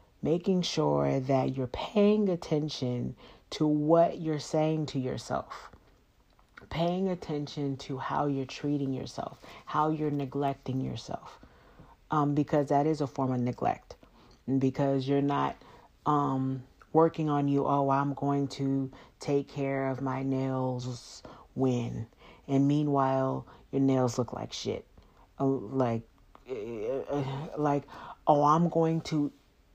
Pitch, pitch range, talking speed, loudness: 140 Hz, 130-150 Hz, 125 wpm, -30 LUFS